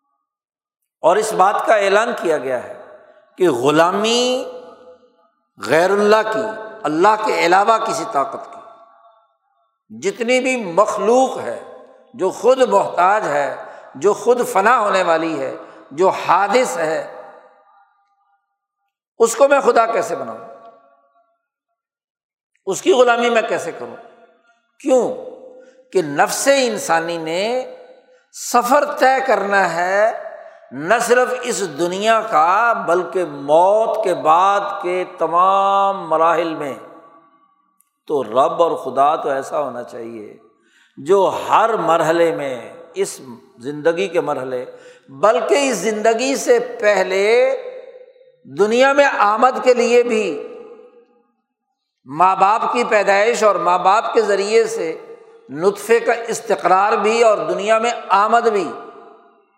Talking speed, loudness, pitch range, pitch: 115 wpm, -16 LUFS, 200-285 Hz, 230 Hz